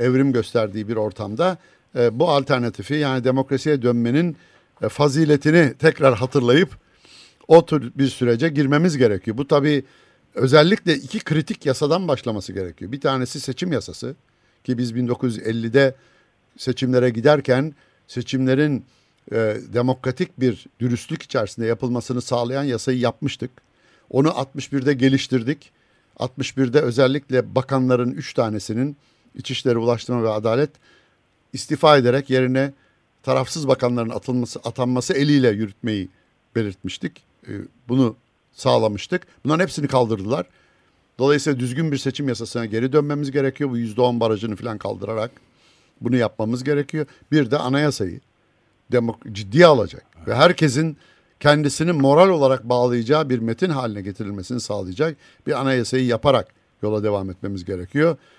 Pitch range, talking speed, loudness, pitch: 115-145 Hz, 115 wpm, -20 LUFS, 130 Hz